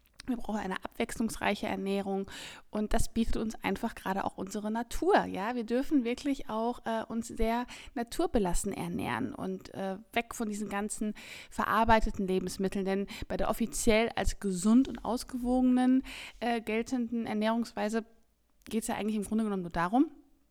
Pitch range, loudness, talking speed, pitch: 205-240 Hz, -32 LUFS, 150 wpm, 225 Hz